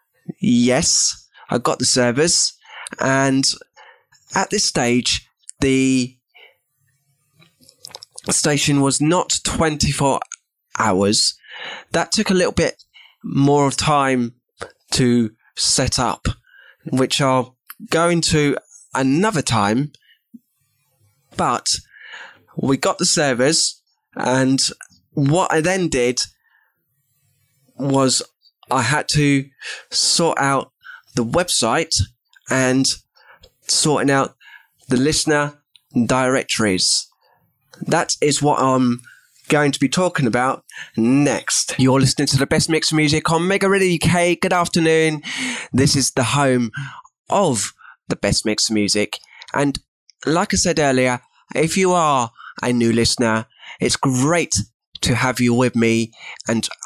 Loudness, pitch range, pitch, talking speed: -18 LUFS, 125-160 Hz, 135 Hz, 115 wpm